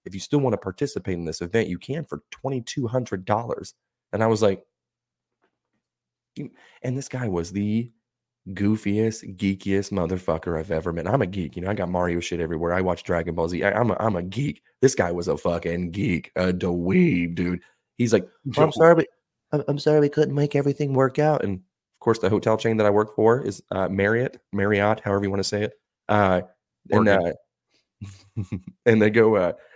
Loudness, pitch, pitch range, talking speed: -23 LUFS, 105 Hz, 90-125 Hz, 200 wpm